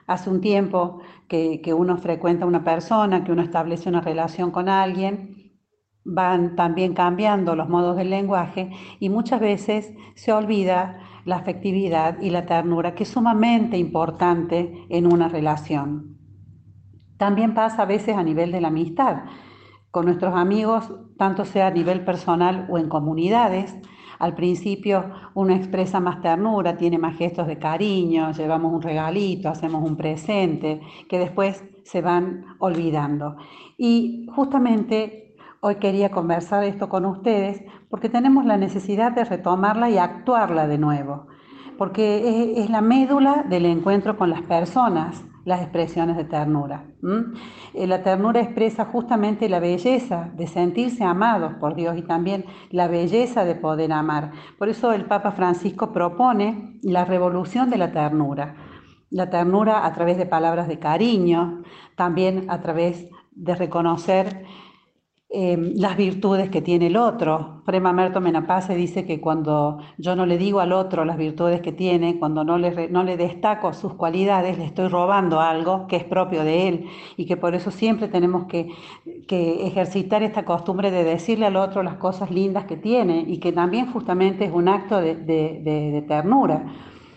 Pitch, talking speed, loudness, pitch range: 180 Hz, 155 wpm, -21 LUFS, 170-200 Hz